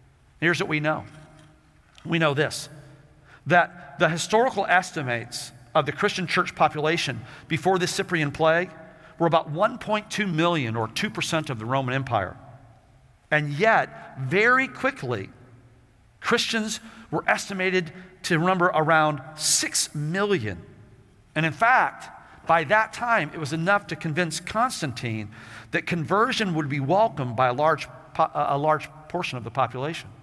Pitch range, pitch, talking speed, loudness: 135-180 Hz, 160 Hz, 135 wpm, -24 LUFS